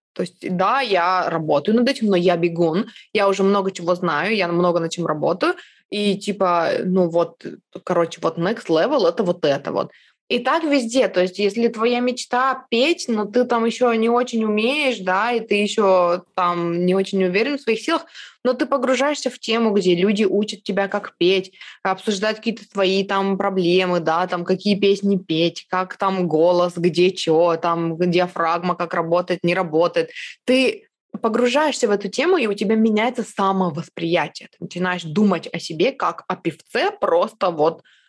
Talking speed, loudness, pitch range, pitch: 175 wpm, -20 LUFS, 180-230 Hz, 195 Hz